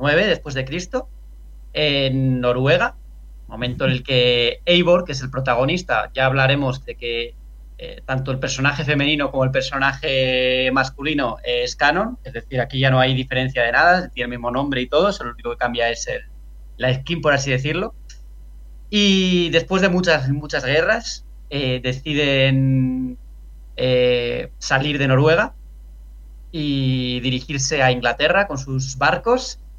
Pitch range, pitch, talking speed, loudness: 125-150 Hz, 130 Hz, 155 wpm, -19 LUFS